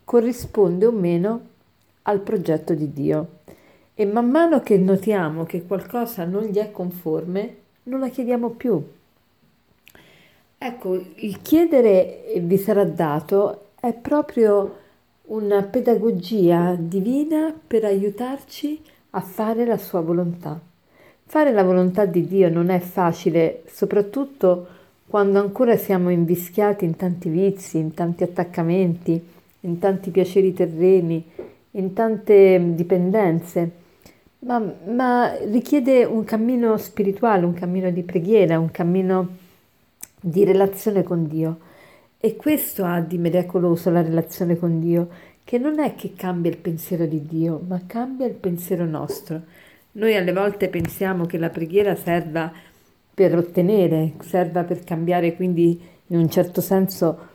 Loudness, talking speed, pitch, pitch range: -21 LUFS, 130 wpm, 190 Hz, 175-215 Hz